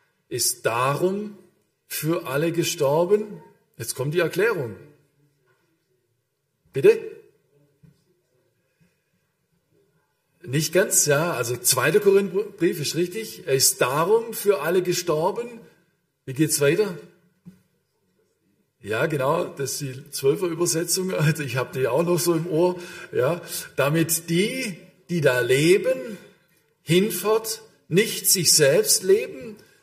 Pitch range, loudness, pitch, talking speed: 145-195 Hz, -22 LUFS, 175 Hz, 110 wpm